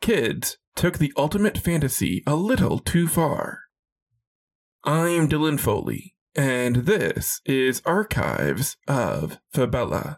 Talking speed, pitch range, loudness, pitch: 105 wpm, 130-170 Hz, -23 LUFS, 150 Hz